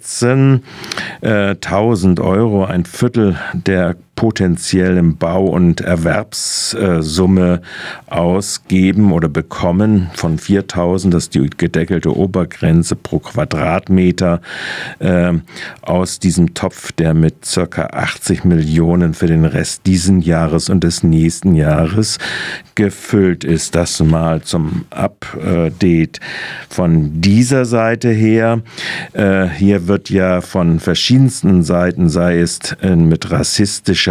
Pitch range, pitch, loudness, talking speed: 85-100 Hz, 90 Hz, -14 LUFS, 110 wpm